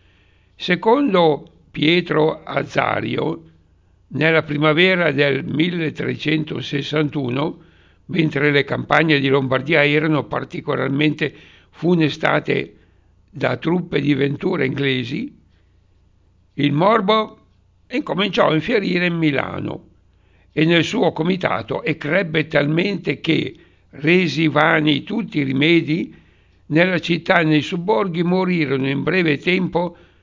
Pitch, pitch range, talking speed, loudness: 150 Hz, 135-170 Hz, 95 wpm, -18 LUFS